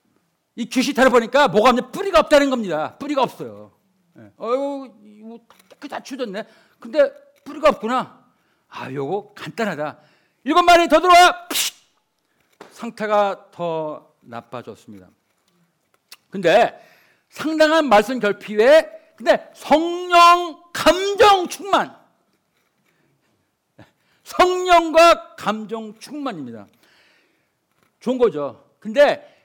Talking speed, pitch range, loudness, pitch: 215 characters per minute, 215-315 Hz, -17 LUFS, 270 Hz